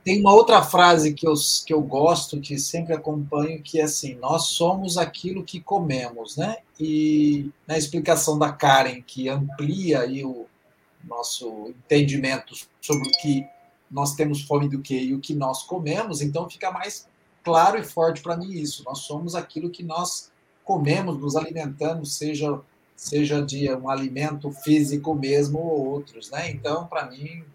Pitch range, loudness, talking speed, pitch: 140-165 Hz, -23 LUFS, 165 wpm, 150 Hz